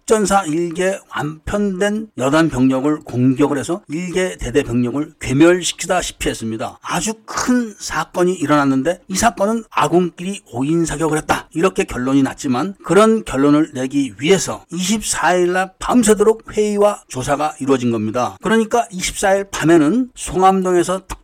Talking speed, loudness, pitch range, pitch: 310 characters per minute, -17 LUFS, 145-200 Hz, 175 Hz